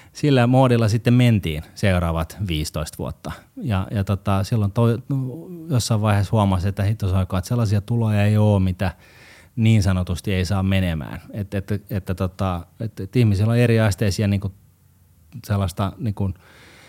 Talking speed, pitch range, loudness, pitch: 155 wpm, 95-115 Hz, -21 LUFS, 100 Hz